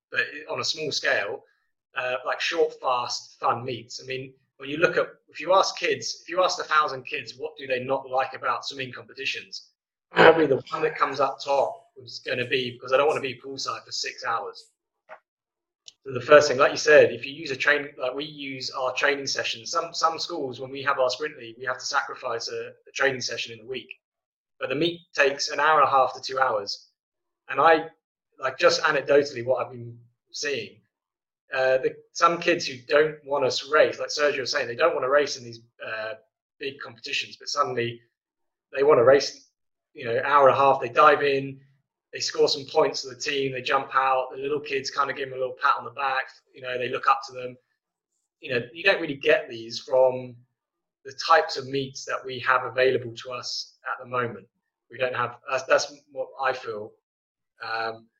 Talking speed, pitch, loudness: 220 wpm, 145 Hz, -24 LUFS